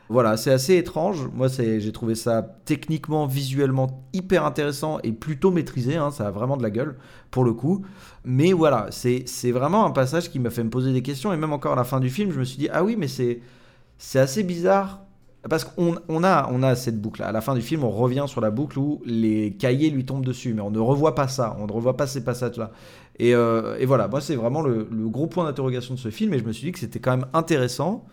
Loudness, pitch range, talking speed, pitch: -23 LUFS, 120-155 Hz, 255 wpm, 130 Hz